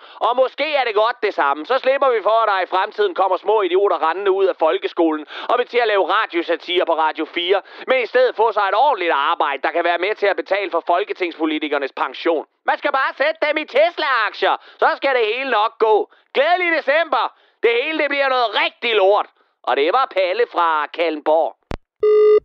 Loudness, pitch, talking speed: -18 LUFS, 240 Hz, 205 wpm